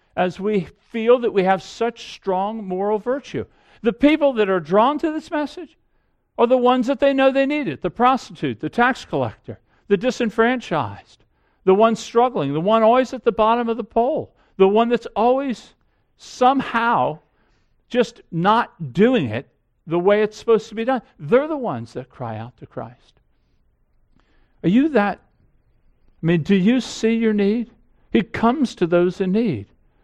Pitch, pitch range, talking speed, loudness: 225 Hz, 190-250 Hz, 170 wpm, -20 LUFS